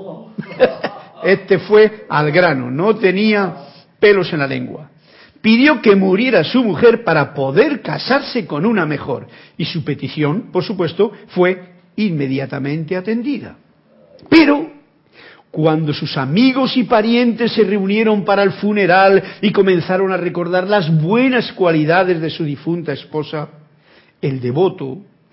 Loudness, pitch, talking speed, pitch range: -15 LUFS, 185 Hz, 125 wpm, 155-215 Hz